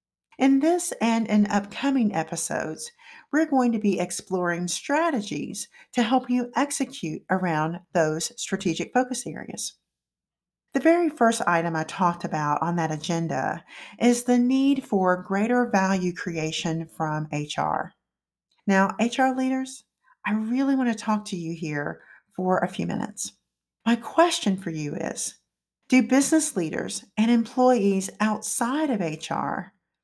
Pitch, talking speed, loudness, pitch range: 210 Hz, 135 wpm, -25 LUFS, 175-260 Hz